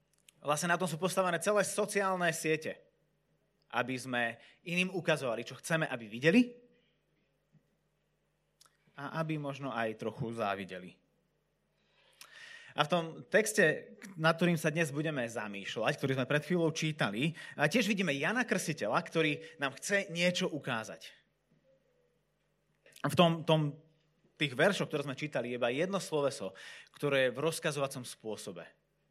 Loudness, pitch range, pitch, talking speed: -33 LUFS, 135-175 Hz, 155 Hz, 130 wpm